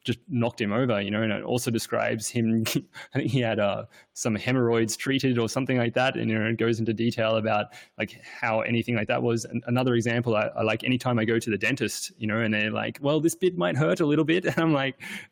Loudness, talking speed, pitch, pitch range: -26 LUFS, 255 wpm, 115 Hz, 110-130 Hz